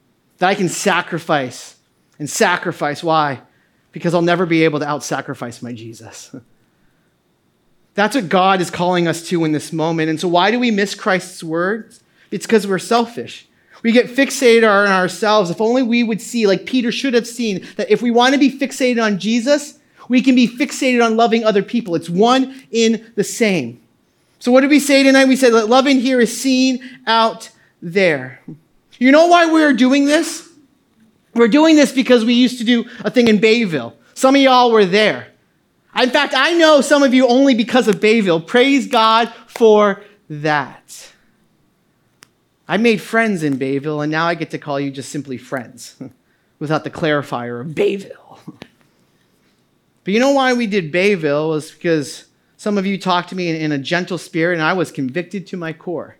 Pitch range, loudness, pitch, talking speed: 165-245 Hz, -15 LUFS, 210 Hz, 185 wpm